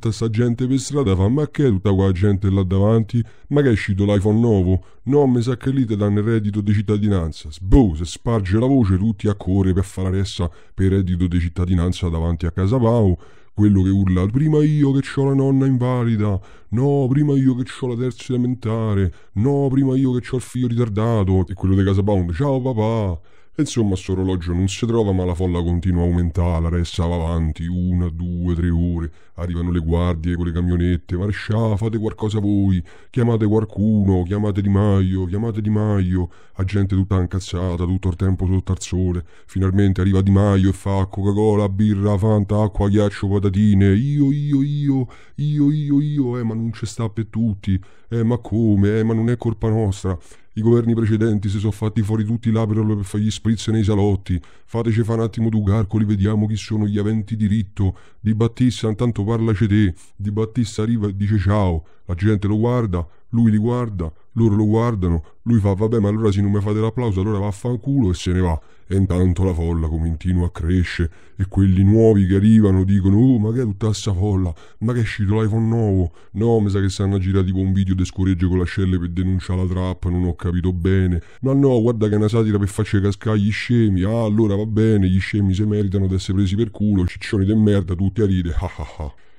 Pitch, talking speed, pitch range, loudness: 105 Hz, 210 wpm, 95-115 Hz, -19 LUFS